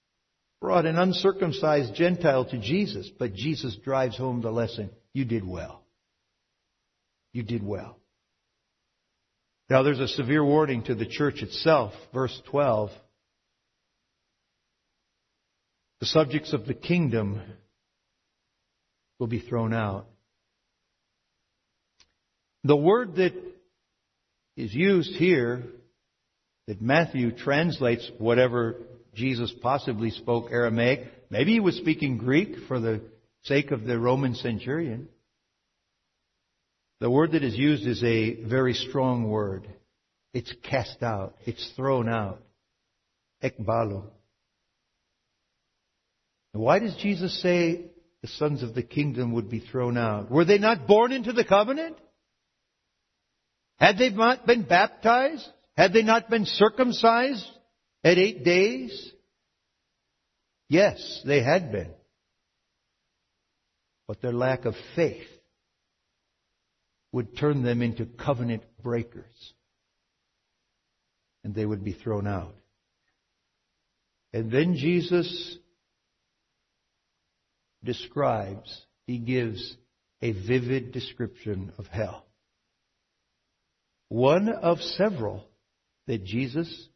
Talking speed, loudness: 105 wpm, -25 LUFS